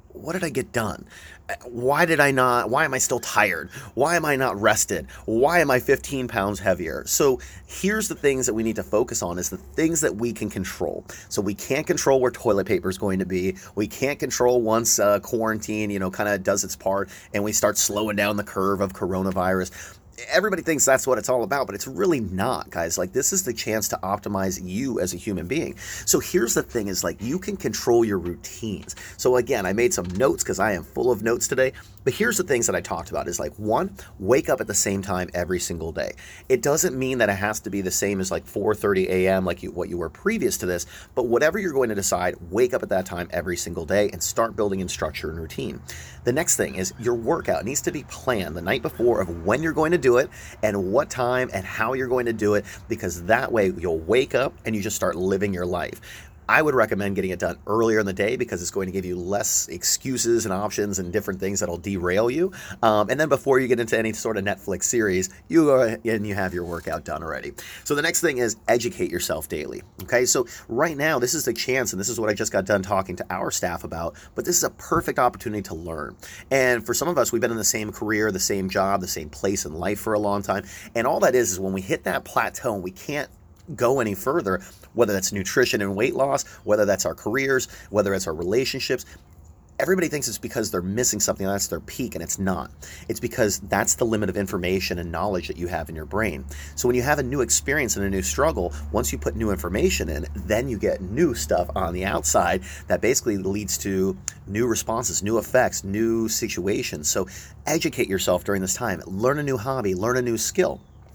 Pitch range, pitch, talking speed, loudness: 95-120 Hz, 100 Hz, 240 wpm, -23 LUFS